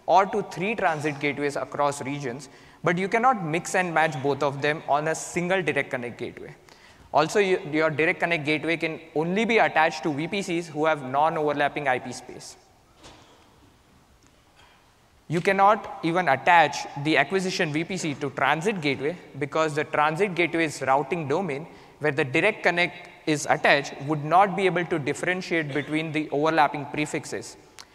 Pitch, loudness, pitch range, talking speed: 155 Hz, -24 LUFS, 145-180 Hz, 150 wpm